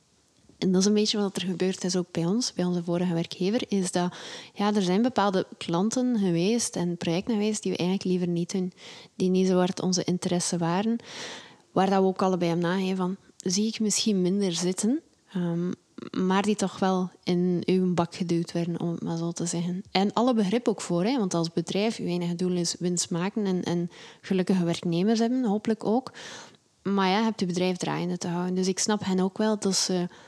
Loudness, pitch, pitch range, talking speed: -27 LUFS, 185 Hz, 175-200 Hz, 210 wpm